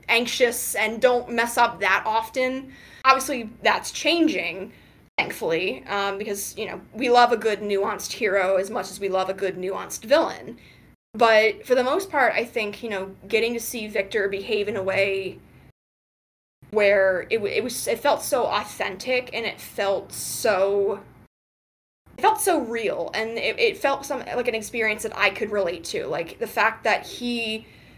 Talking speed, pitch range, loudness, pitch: 175 wpm, 200-255 Hz, -23 LUFS, 225 Hz